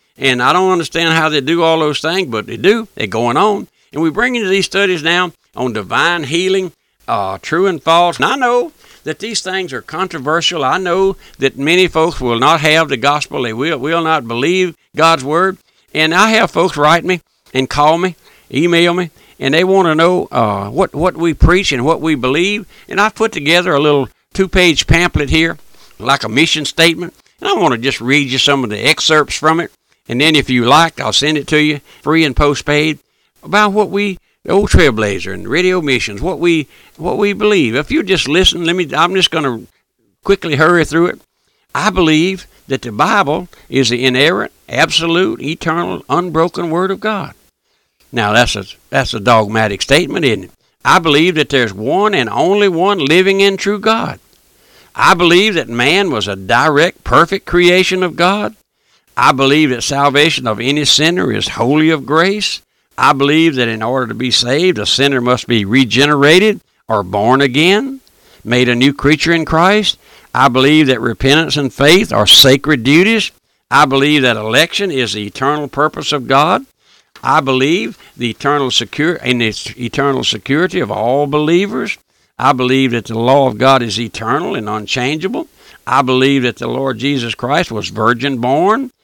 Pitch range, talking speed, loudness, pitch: 130-180 Hz, 185 wpm, -12 LUFS, 155 Hz